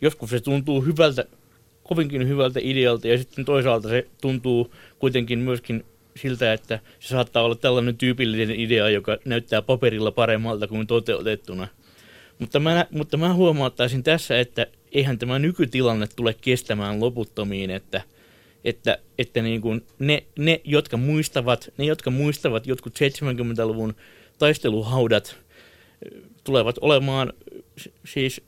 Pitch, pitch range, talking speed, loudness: 125 Hz, 115-135 Hz, 125 wpm, -23 LUFS